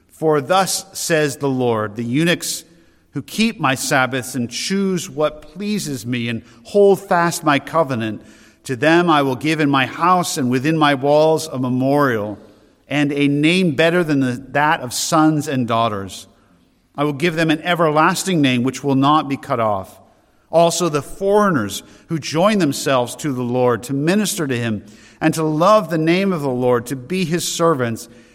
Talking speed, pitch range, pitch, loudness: 175 wpm, 125-165 Hz, 145 Hz, -17 LUFS